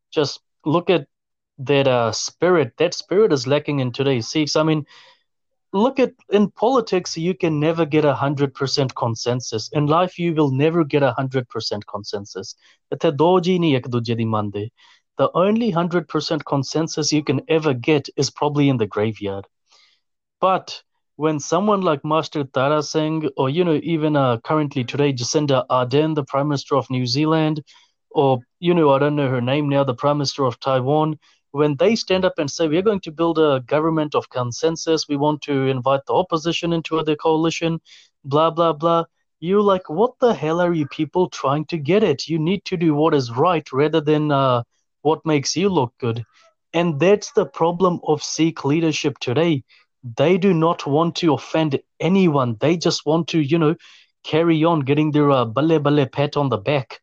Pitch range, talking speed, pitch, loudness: 135-165 Hz, 180 wpm, 155 Hz, -20 LUFS